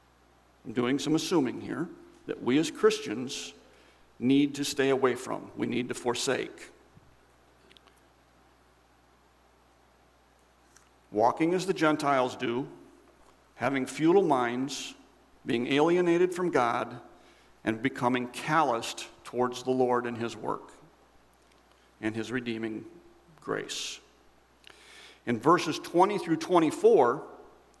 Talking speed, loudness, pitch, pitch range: 105 wpm, -28 LUFS, 130 Hz, 115-165 Hz